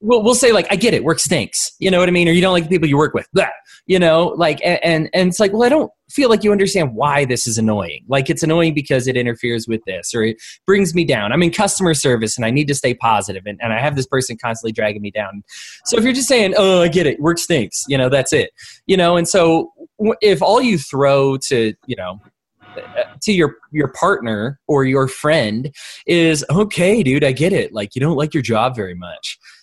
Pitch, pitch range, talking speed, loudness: 155 Hz, 120-185 Hz, 245 wpm, -16 LUFS